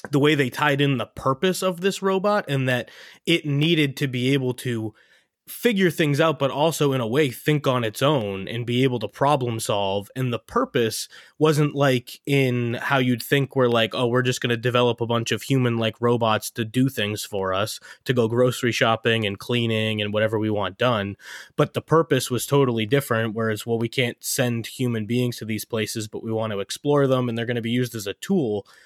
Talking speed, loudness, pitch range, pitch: 220 wpm, -23 LUFS, 115-140 Hz, 125 Hz